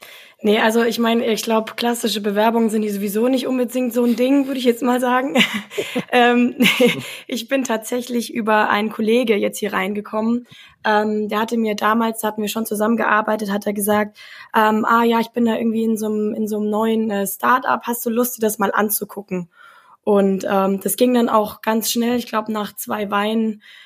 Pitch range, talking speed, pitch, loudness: 210-240 Hz, 195 wpm, 220 Hz, -19 LUFS